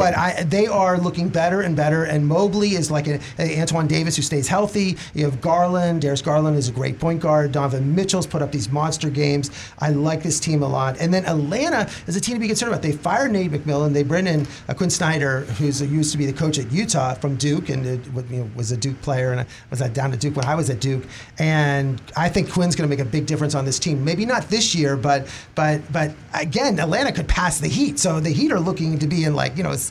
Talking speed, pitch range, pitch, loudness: 255 wpm, 140-170 Hz, 150 Hz, -21 LUFS